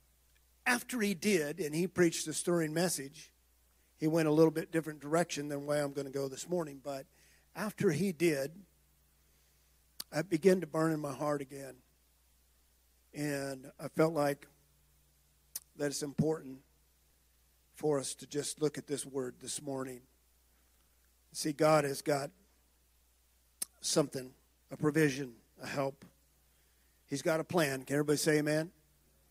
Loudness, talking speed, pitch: -34 LUFS, 145 wpm, 140 Hz